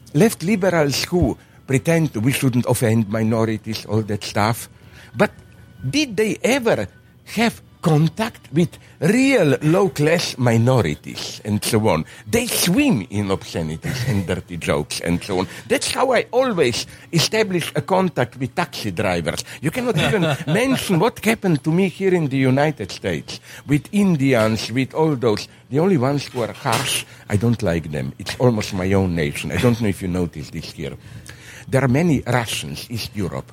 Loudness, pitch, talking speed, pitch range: -20 LUFS, 125 Hz, 165 wpm, 105-155 Hz